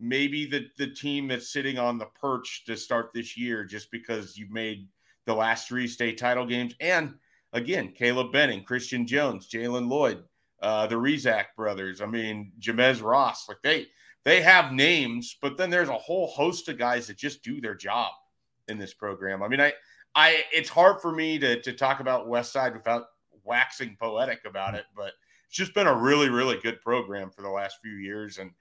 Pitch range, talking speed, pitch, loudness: 110-135 Hz, 195 wpm, 120 Hz, -26 LUFS